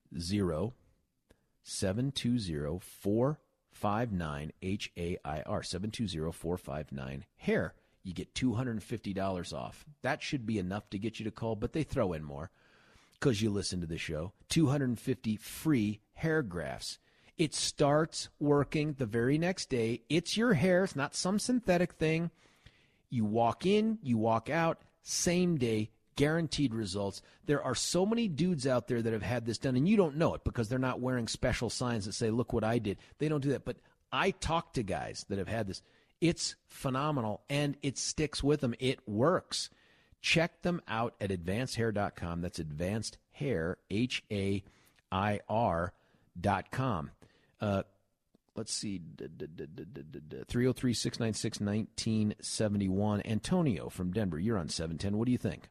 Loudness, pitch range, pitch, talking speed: -33 LUFS, 100-140 Hz, 115 Hz, 165 wpm